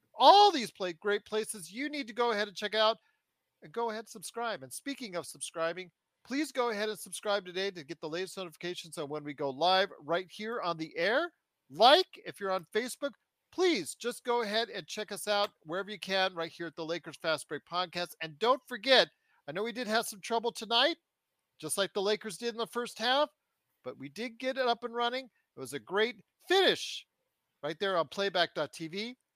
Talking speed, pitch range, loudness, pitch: 210 wpm, 170-240 Hz, -32 LUFS, 205 Hz